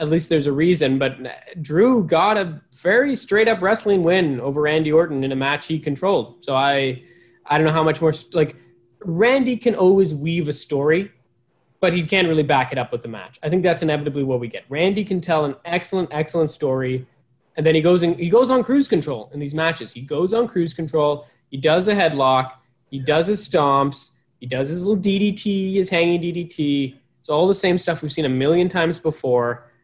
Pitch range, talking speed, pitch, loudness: 140-180 Hz, 210 wpm, 160 Hz, -19 LUFS